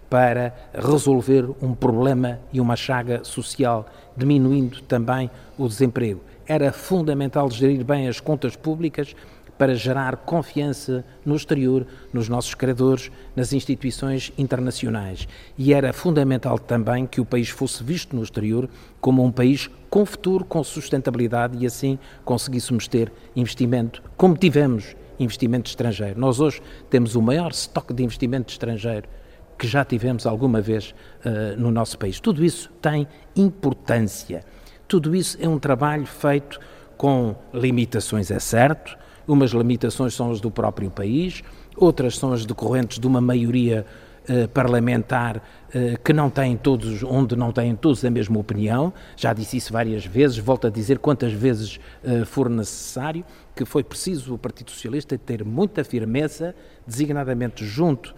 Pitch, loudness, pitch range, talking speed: 130 Hz, -22 LUFS, 120-140 Hz, 145 wpm